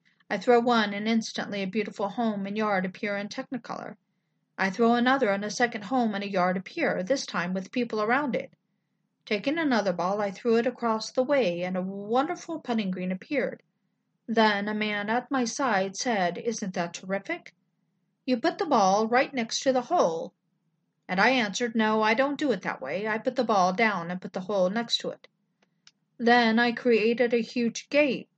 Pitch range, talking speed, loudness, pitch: 190-245 Hz, 195 wpm, -27 LUFS, 220 Hz